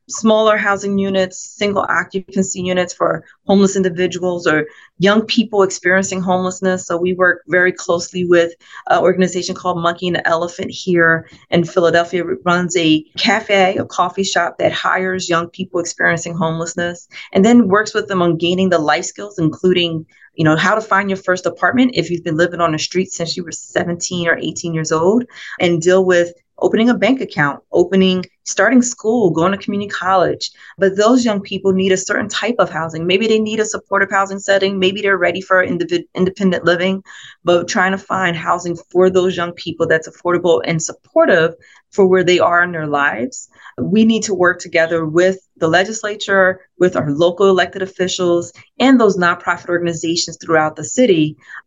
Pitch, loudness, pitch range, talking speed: 180 Hz, -15 LUFS, 170-195 Hz, 180 wpm